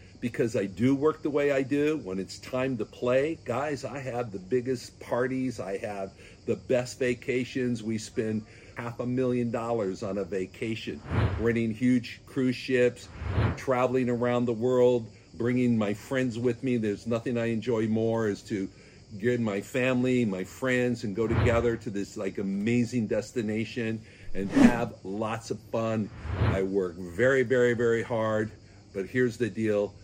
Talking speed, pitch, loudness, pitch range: 160 wpm, 115 Hz, -28 LUFS, 105-125 Hz